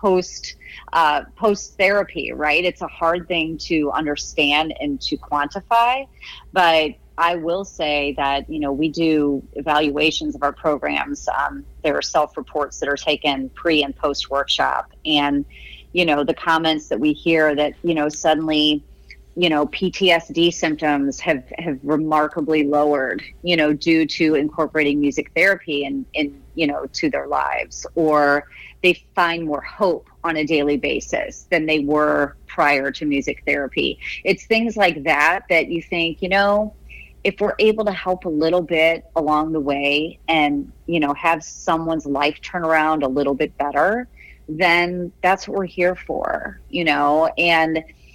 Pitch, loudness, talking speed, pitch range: 155 Hz, -19 LUFS, 165 wpm, 145-175 Hz